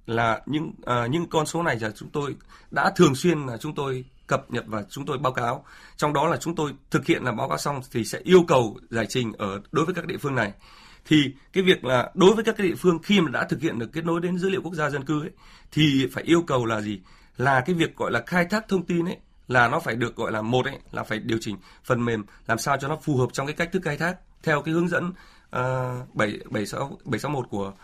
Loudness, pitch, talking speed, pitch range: -25 LUFS, 145 Hz, 265 wpm, 120-170 Hz